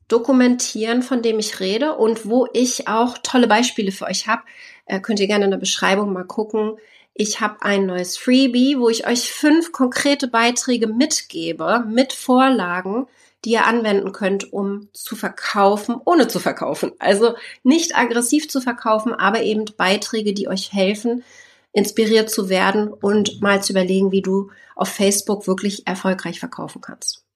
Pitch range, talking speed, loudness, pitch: 200-245 Hz, 160 wpm, -18 LUFS, 220 Hz